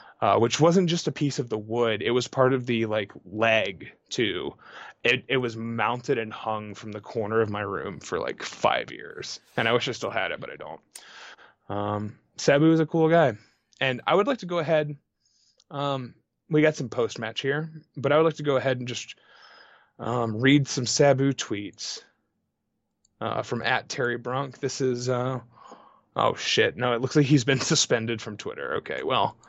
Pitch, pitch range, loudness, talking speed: 130 Hz, 115-145 Hz, -25 LUFS, 200 wpm